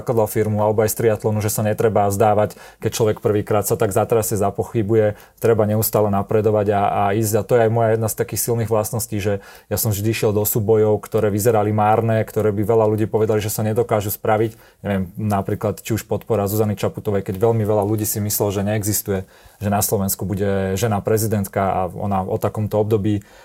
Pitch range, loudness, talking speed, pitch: 105-110 Hz, -19 LUFS, 200 wpm, 105 Hz